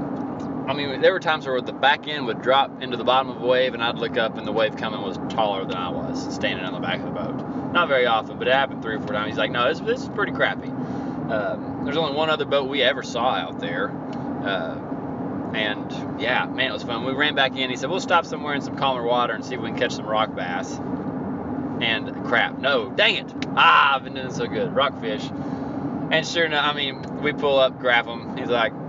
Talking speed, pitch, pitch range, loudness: 245 wpm, 135 Hz, 125-145 Hz, -23 LUFS